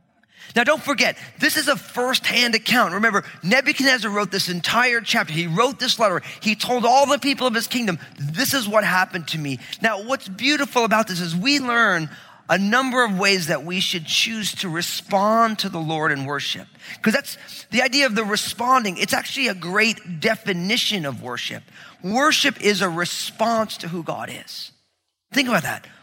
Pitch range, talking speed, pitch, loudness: 180-245 Hz, 185 wpm, 215 Hz, -20 LUFS